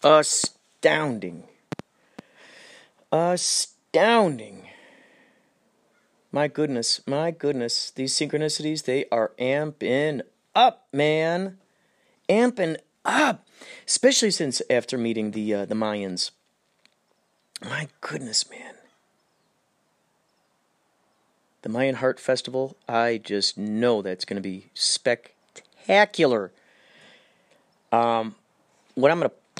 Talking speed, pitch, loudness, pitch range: 80 wpm, 135 Hz, -24 LUFS, 115-155 Hz